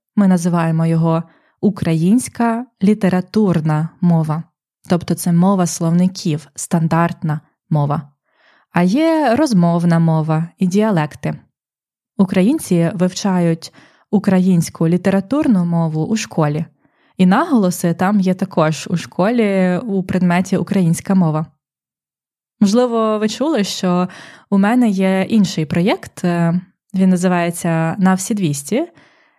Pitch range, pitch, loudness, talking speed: 165-200 Hz, 180 Hz, -16 LUFS, 100 wpm